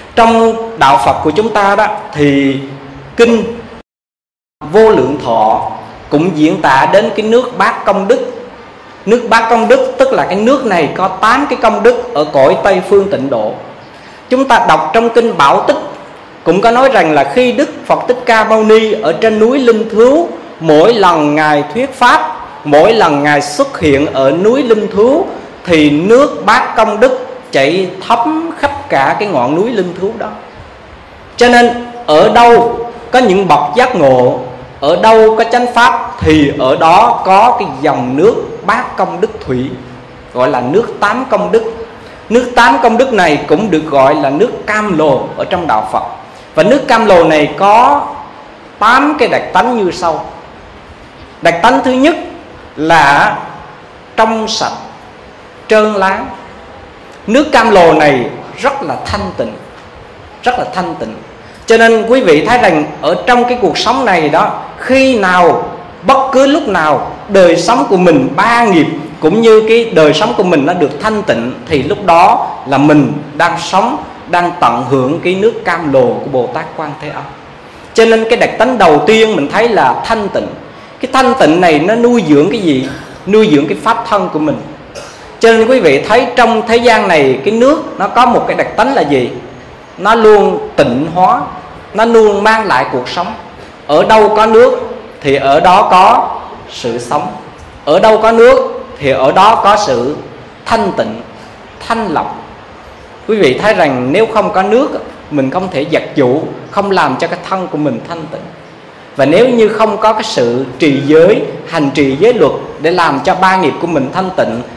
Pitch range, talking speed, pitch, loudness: 170-240 Hz, 185 wpm, 220 Hz, -9 LUFS